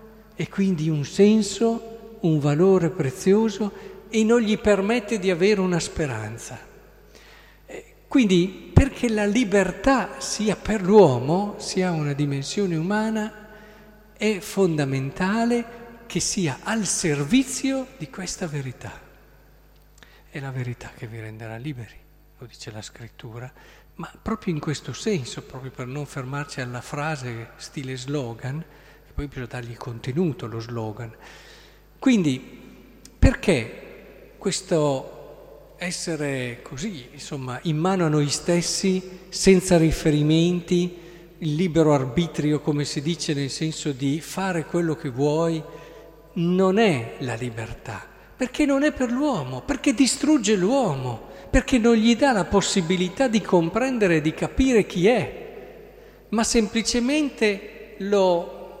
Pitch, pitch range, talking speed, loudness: 175 Hz, 145-215 Hz, 120 wpm, -23 LUFS